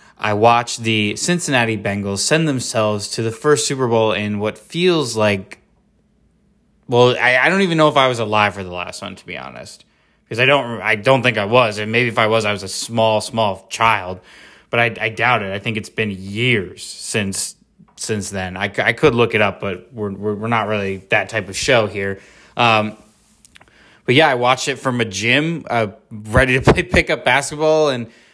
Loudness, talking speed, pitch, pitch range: -17 LUFS, 210 wpm, 115 Hz, 105-125 Hz